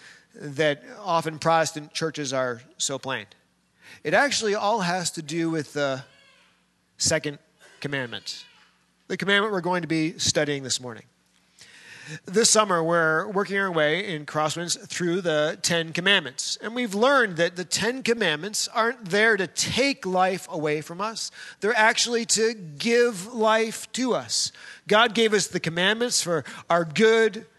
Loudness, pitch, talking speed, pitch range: -23 LUFS, 180 Hz, 150 wpm, 155-220 Hz